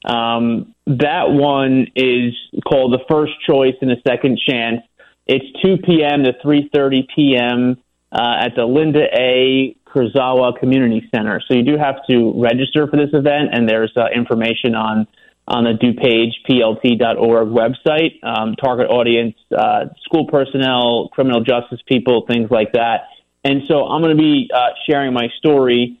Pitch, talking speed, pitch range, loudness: 125 Hz, 155 wpm, 120-145 Hz, -15 LUFS